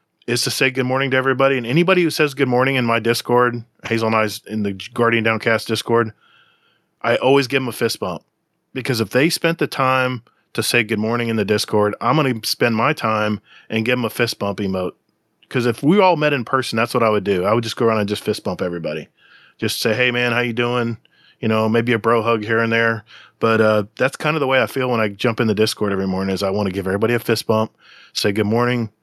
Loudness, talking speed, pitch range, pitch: -18 LUFS, 255 wpm, 110-130 Hz, 115 Hz